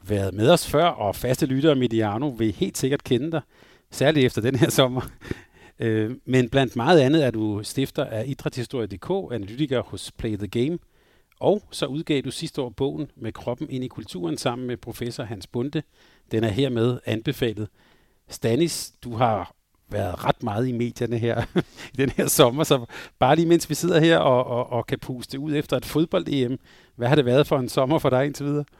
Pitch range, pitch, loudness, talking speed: 115-150 Hz, 130 Hz, -23 LUFS, 195 wpm